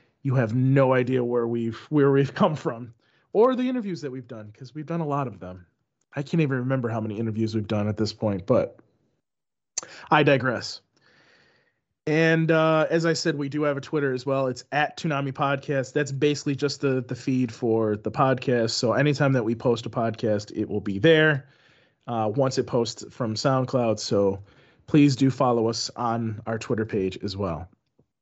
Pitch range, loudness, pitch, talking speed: 115-145 Hz, -24 LUFS, 130 Hz, 195 wpm